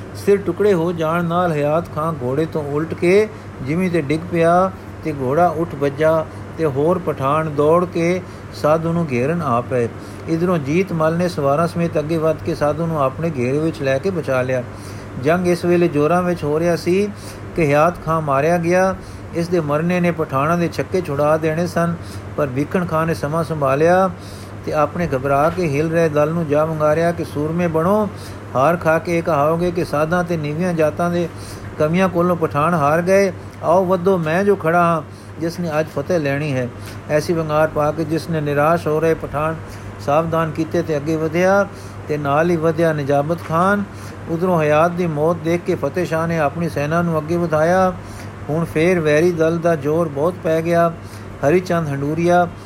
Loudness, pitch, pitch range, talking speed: -18 LUFS, 160 Hz, 145-175 Hz, 185 wpm